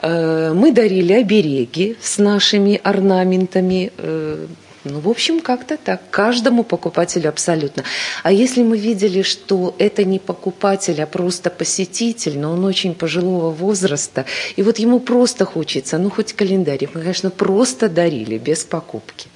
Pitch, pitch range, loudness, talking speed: 185 Hz, 165-210 Hz, -17 LUFS, 135 wpm